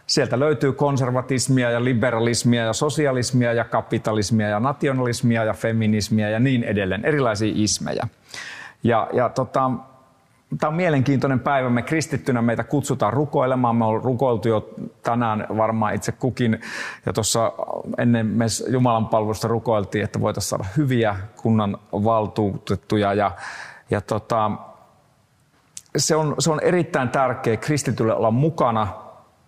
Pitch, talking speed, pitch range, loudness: 120 Hz, 125 wpm, 110-130 Hz, -21 LUFS